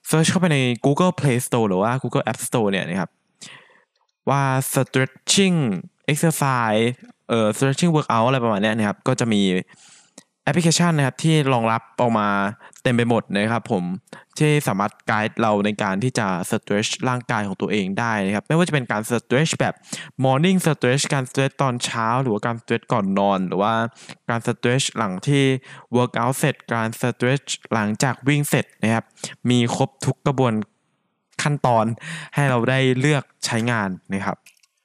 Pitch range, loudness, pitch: 110-145 Hz, -21 LUFS, 125 Hz